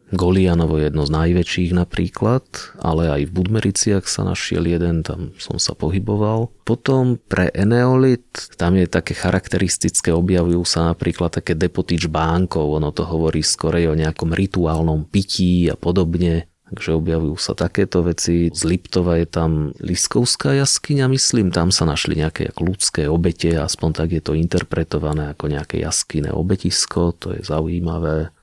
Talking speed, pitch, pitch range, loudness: 150 wpm, 85 Hz, 80-95 Hz, -19 LUFS